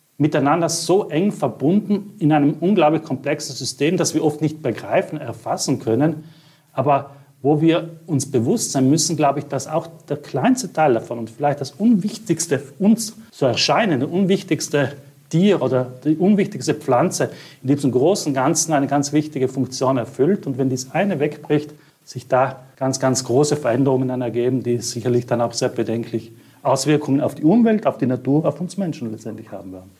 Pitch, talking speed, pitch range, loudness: 145 Hz, 170 wpm, 130-160 Hz, -20 LUFS